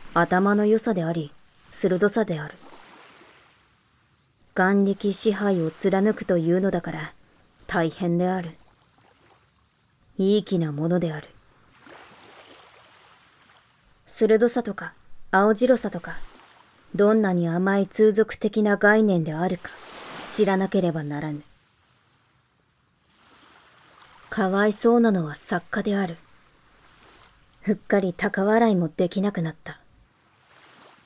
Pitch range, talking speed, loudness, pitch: 170-210 Hz, 195 characters per minute, -23 LUFS, 190 Hz